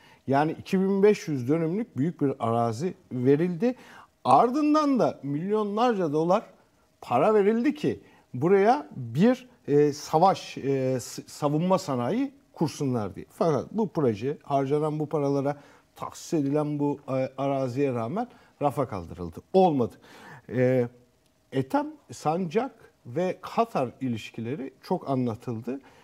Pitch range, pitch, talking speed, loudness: 130-195 Hz, 145 Hz, 95 wpm, -26 LUFS